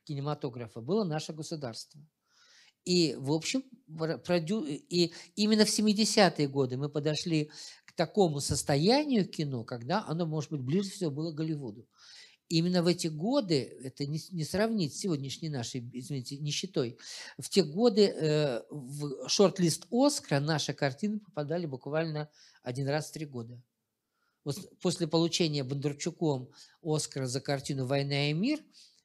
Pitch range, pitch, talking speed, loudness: 145-180 Hz, 155 Hz, 130 wpm, -31 LUFS